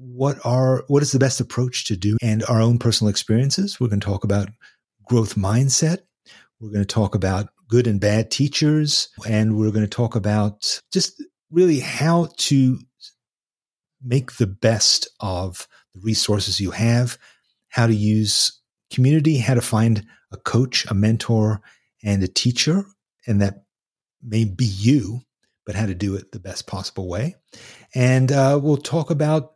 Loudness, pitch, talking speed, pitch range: -20 LUFS, 115 Hz, 165 wpm, 105-135 Hz